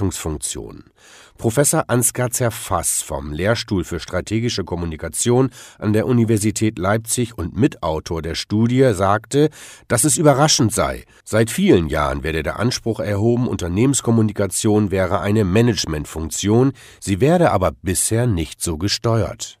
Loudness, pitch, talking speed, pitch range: -18 LUFS, 110 Hz, 120 wpm, 90-120 Hz